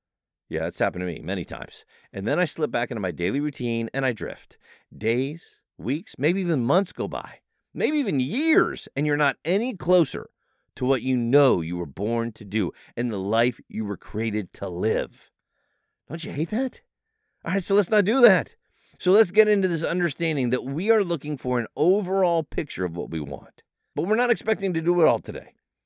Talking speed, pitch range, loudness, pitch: 205 wpm, 115-190 Hz, -24 LUFS, 145 Hz